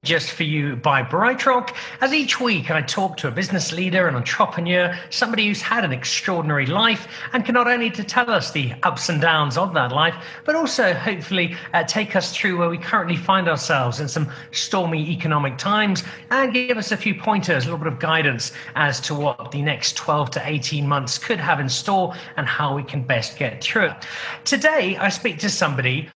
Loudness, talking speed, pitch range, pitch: -20 LUFS, 210 wpm, 150-205 Hz, 170 Hz